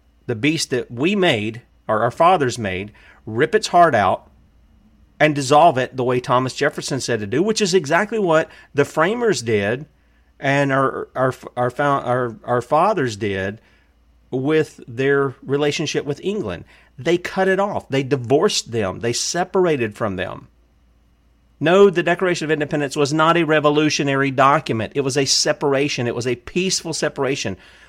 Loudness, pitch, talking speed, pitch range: -19 LUFS, 140 Hz, 155 wpm, 115-155 Hz